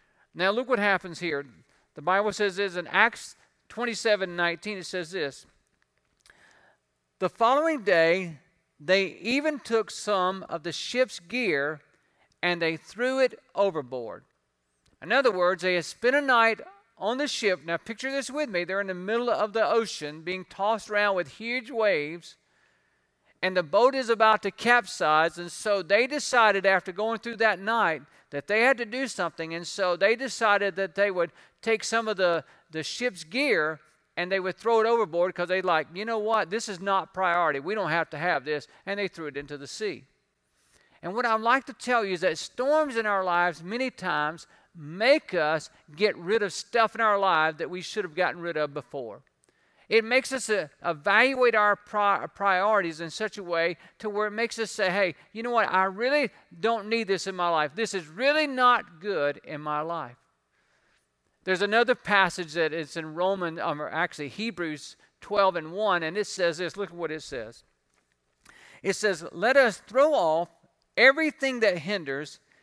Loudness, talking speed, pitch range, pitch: -26 LUFS, 185 wpm, 170-225 Hz, 195 Hz